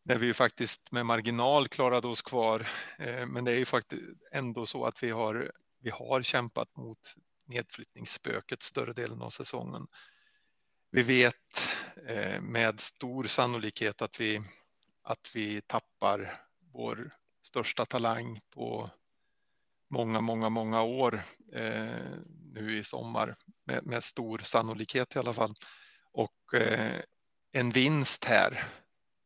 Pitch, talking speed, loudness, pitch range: 120 Hz, 120 wpm, -32 LUFS, 110-130 Hz